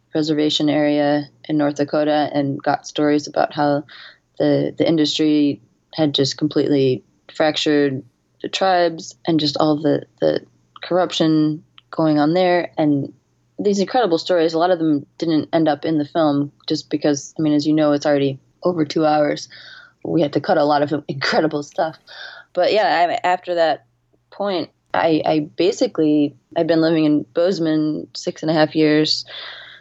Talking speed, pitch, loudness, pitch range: 165 wpm, 155 Hz, -19 LUFS, 145-165 Hz